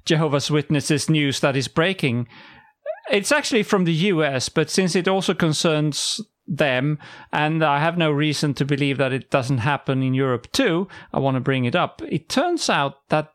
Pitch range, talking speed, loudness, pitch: 140-175 Hz, 185 wpm, -21 LUFS, 155 Hz